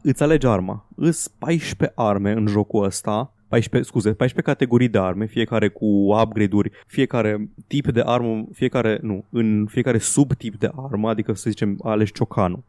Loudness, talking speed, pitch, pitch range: -21 LUFS, 160 wpm, 110 Hz, 105-125 Hz